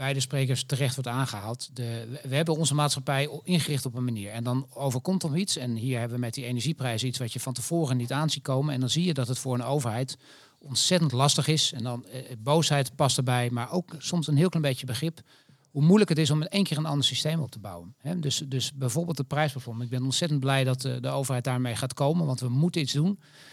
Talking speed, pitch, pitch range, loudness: 245 wpm, 135 Hz, 125-155 Hz, -27 LUFS